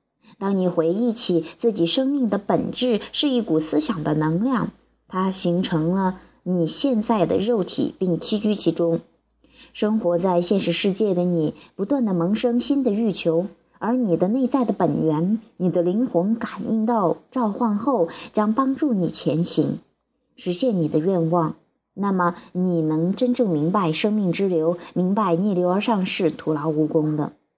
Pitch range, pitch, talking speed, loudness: 170-225 Hz, 190 Hz, 235 characters per minute, -22 LUFS